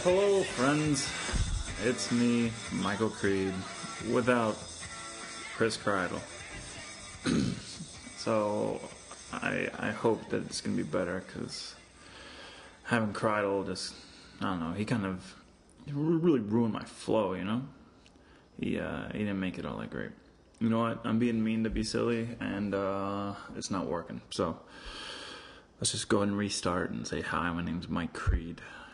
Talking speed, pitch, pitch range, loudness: 150 wpm, 105 Hz, 95-115 Hz, -32 LUFS